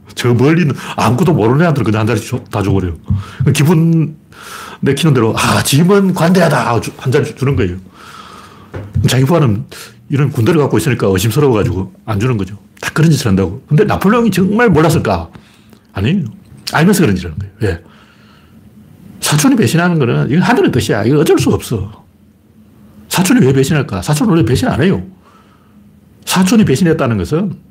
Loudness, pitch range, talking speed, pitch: -12 LUFS, 105-160 Hz, 365 characters per minute, 125 Hz